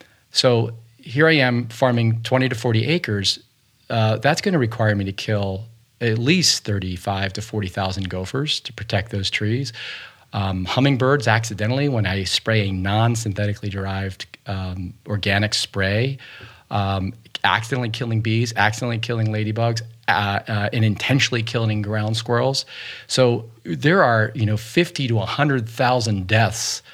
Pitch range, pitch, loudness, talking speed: 105-125 Hz, 110 Hz, -21 LUFS, 140 wpm